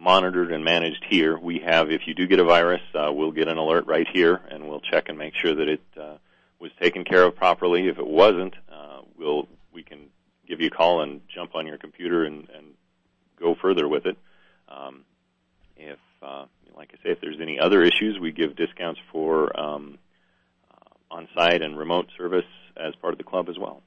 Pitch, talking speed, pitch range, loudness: 80 Hz, 205 wpm, 75-85 Hz, -22 LUFS